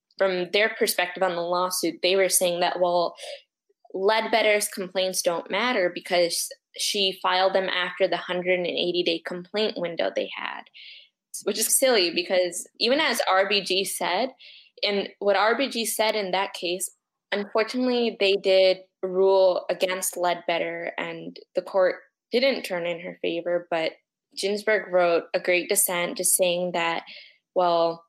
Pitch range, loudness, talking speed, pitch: 175-205 Hz, -24 LUFS, 140 wpm, 185 Hz